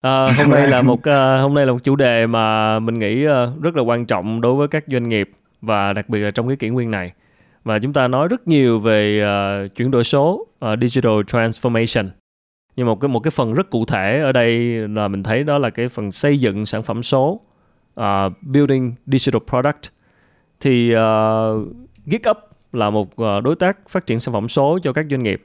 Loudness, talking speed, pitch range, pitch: -17 LUFS, 215 wpm, 110-135 Hz, 120 Hz